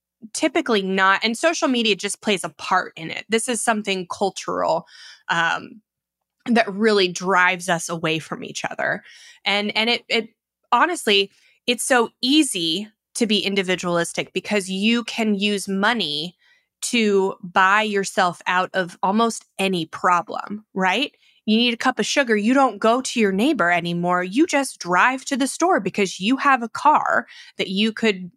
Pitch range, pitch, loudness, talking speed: 185-240 Hz, 210 Hz, -20 LUFS, 160 wpm